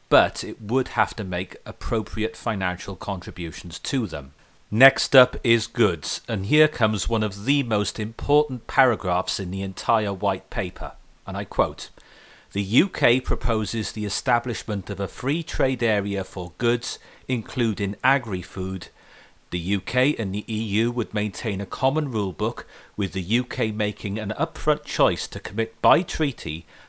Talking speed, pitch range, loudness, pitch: 150 wpm, 100-120 Hz, -24 LUFS, 110 Hz